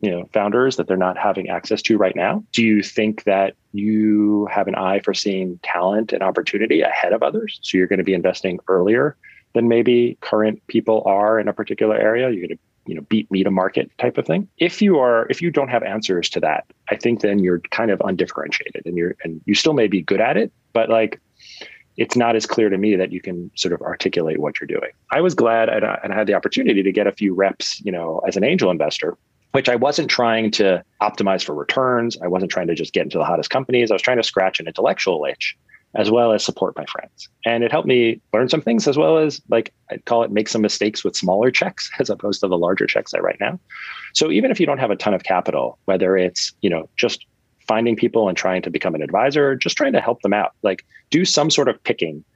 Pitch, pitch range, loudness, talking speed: 110 Hz, 95-120 Hz, -19 LUFS, 245 wpm